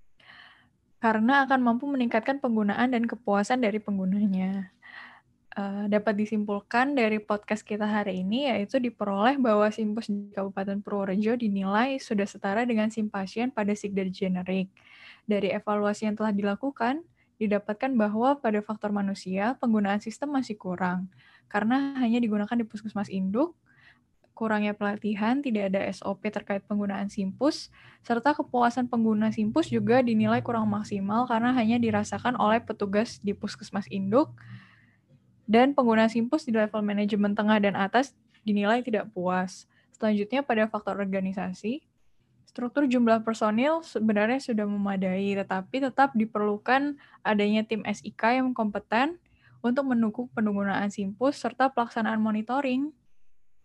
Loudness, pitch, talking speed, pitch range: -27 LUFS, 215 Hz, 125 wpm, 205-240 Hz